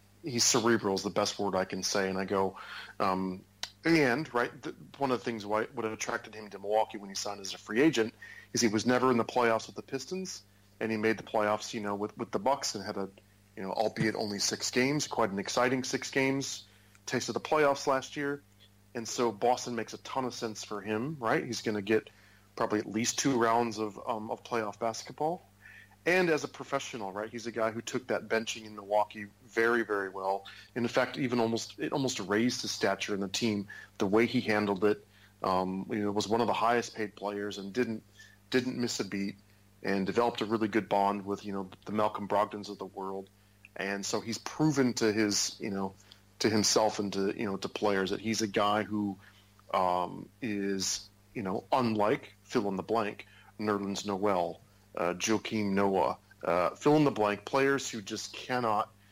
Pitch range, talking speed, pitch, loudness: 100-120 Hz, 210 wpm, 105 Hz, -31 LUFS